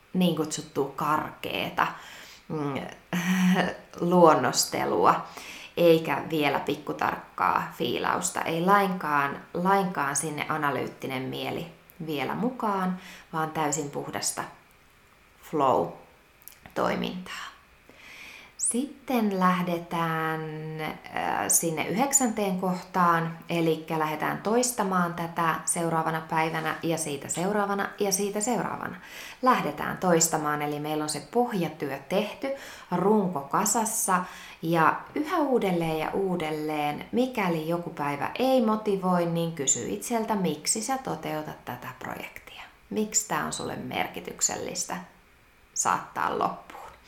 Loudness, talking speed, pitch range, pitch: -27 LUFS, 95 wpm, 155-200 Hz, 170 Hz